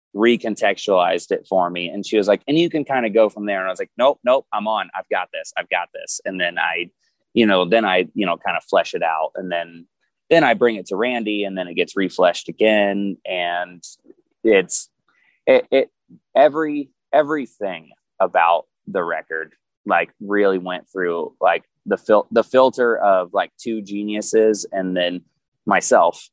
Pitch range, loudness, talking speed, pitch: 95-150 Hz, -19 LUFS, 190 wpm, 110 Hz